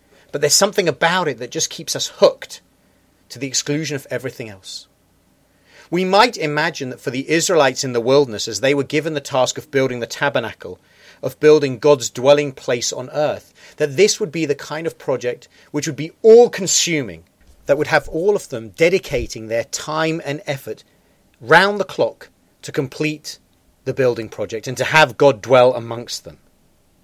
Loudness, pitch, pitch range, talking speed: -17 LUFS, 145 Hz, 125-160 Hz, 180 wpm